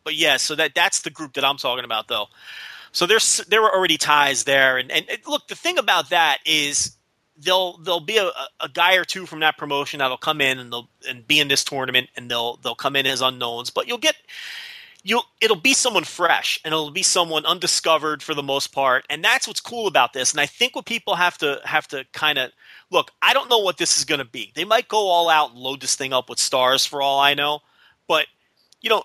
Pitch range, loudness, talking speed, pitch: 135-185 Hz, -19 LUFS, 245 wpm, 150 Hz